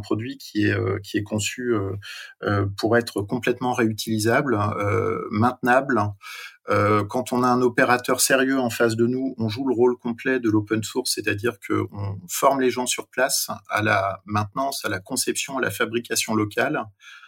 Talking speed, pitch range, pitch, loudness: 160 wpm, 105-125 Hz, 115 Hz, -23 LUFS